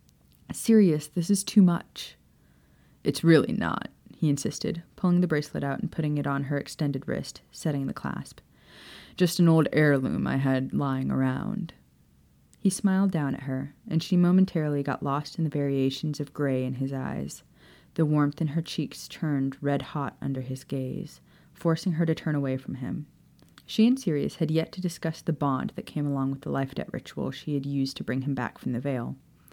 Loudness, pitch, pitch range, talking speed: -27 LUFS, 150 Hz, 135-165 Hz, 190 wpm